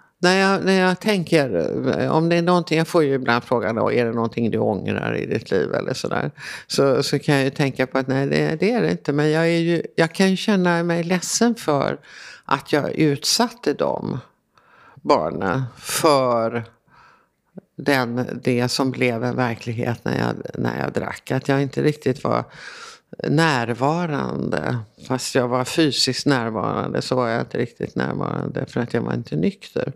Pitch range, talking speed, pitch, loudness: 120-170 Hz, 180 wpm, 140 Hz, -21 LUFS